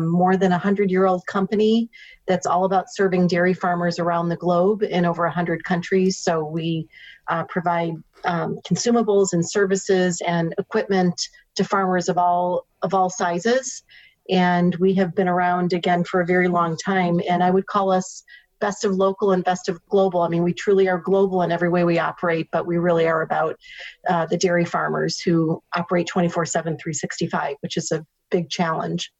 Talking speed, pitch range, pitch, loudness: 185 wpm, 175-195 Hz, 180 Hz, -21 LUFS